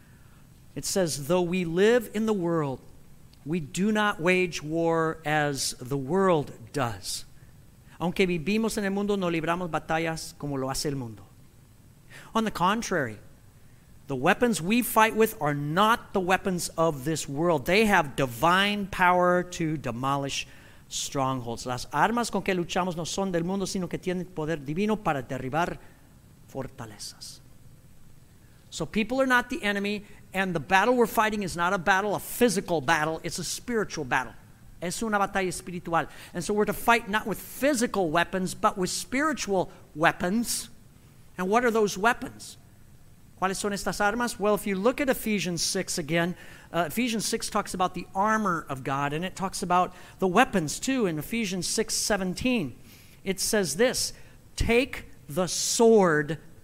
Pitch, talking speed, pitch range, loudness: 175 Hz, 160 wpm, 140-200 Hz, -26 LUFS